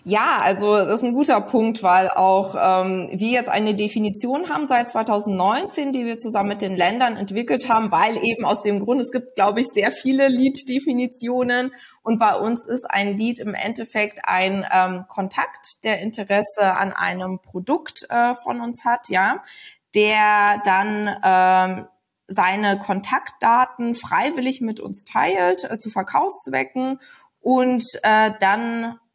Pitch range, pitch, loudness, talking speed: 200-245 Hz, 220 Hz, -20 LUFS, 150 wpm